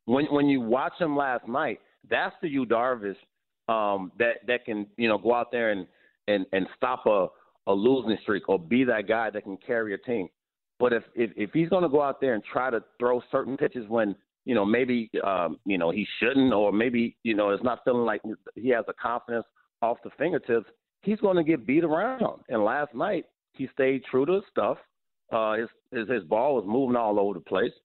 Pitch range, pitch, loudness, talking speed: 105-135 Hz, 120 Hz, -27 LUFS, 220 wpm